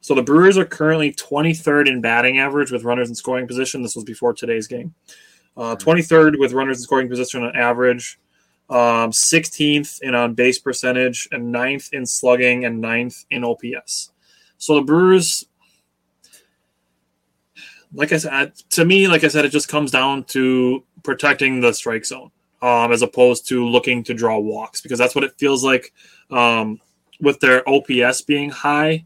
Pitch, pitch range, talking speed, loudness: 125 Hz, 120-145 Hz, 170 wpm, -17 LUFS